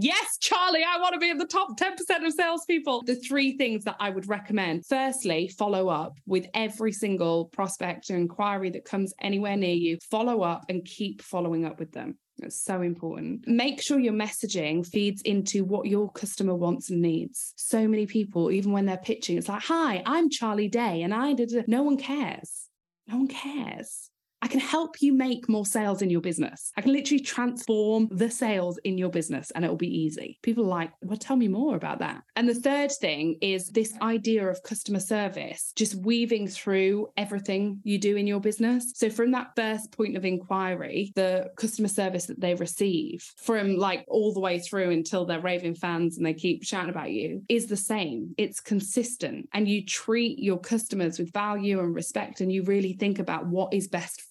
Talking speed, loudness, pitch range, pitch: 200 wpm, -27 LUFS, 185-235 Hz, 205 Hz